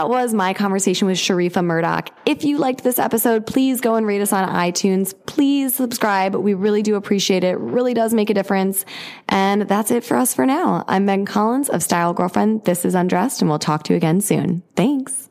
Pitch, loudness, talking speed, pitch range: 205 Hz, -18 LUFS, 220 wpm, 185-235 Hz